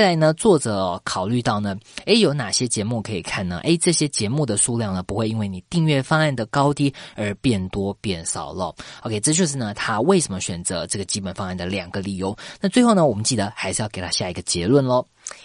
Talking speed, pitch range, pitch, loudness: 340 characters per minute, 100-145 Hz, 110 Hz, -21 LUFS